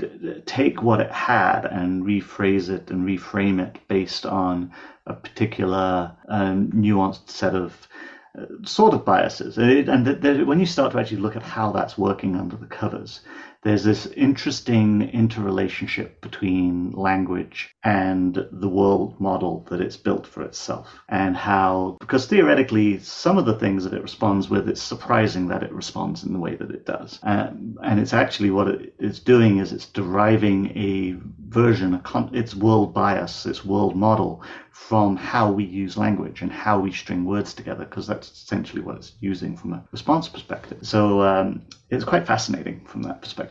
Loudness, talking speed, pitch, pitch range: -22 LUFS, 175 wpm, 100 Hz, 95-110 Hz